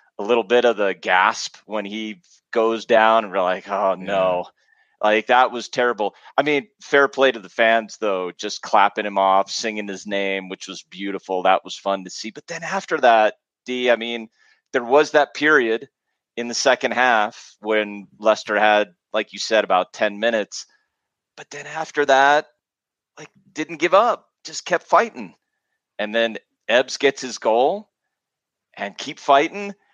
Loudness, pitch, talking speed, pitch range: -20 LUFS, 115 Hz, 170 wpm, 100-140 Hz